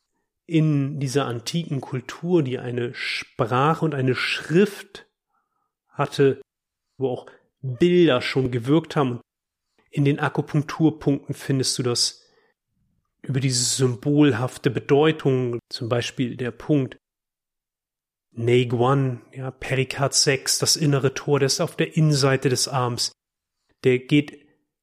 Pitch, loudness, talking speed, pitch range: 135 Hz, -22 LUFS, 115 wpm, 125-150 Hz